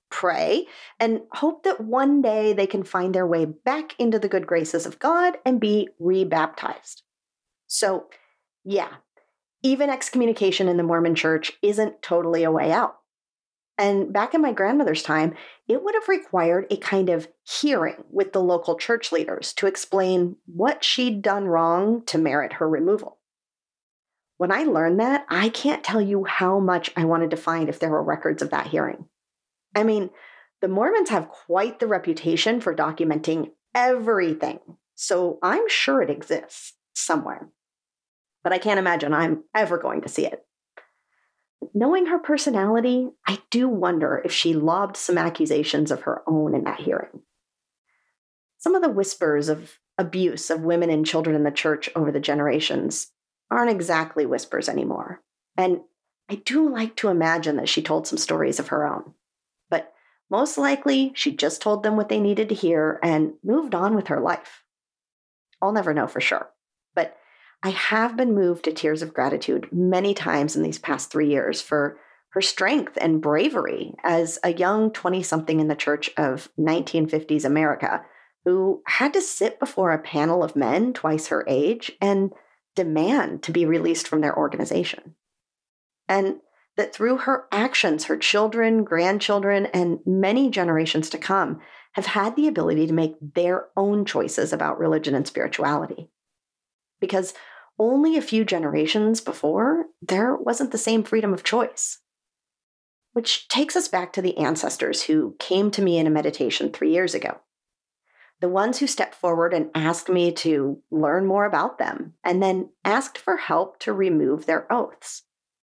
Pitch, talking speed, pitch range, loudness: 185 Hz, 160 wpm, 160-225 Hz, -23 LUFS